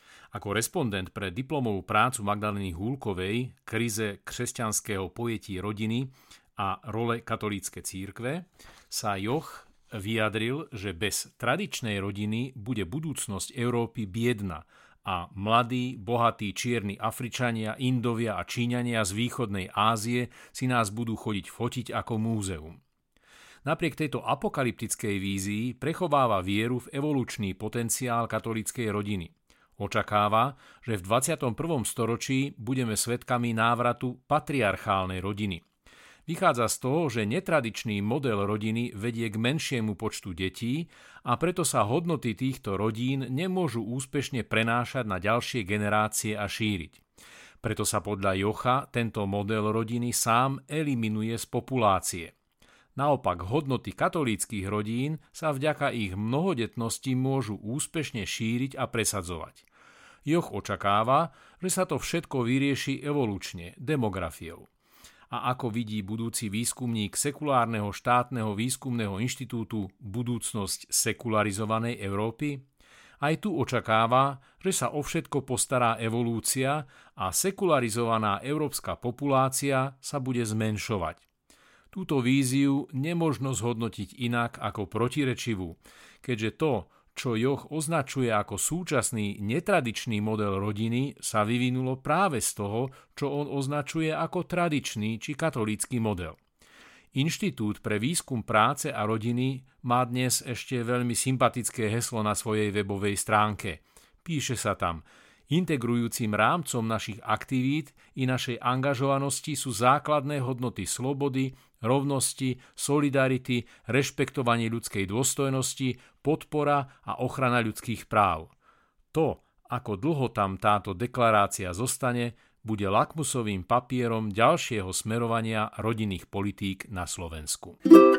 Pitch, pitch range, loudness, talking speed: 120 Hz, 105-135 Hz, -28 LUFS, 110 wpm